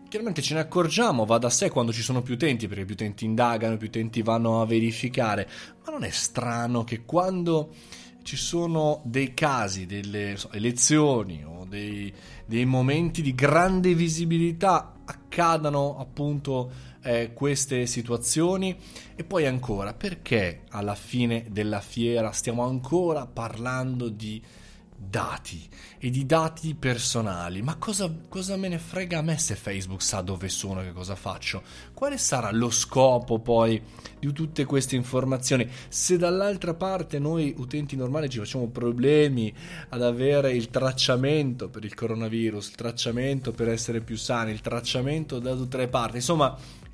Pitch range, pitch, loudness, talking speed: 115-150 Hz, 125 Hz, -26 LUFS, 150 wpm